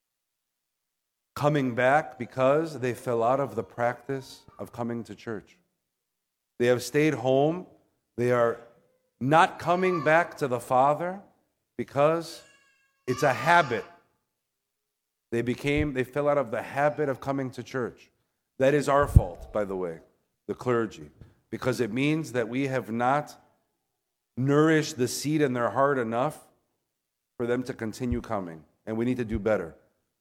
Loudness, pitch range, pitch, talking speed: -27 LUFS, 120-145 Hz, 130 Hz, 150 wpm